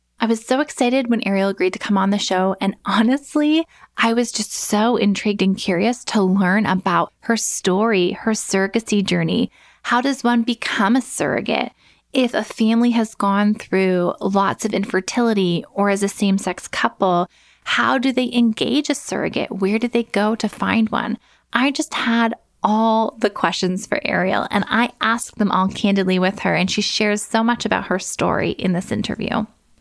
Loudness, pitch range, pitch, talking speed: -19 LUFS, 195-235 Hz, 215 Hz, 180 wpm